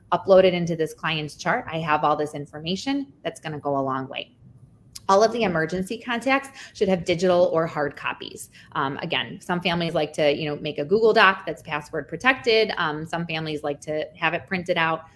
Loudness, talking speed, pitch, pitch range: -23 LUFS, 205 wpm, 165 Hz, 150-190 Hz